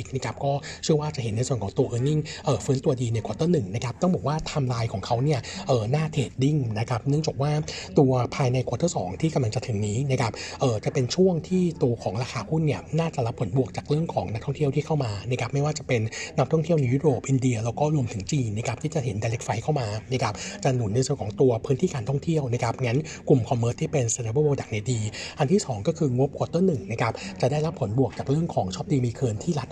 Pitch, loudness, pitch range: 135 Hz, -26 LUFS, 120-150 Hz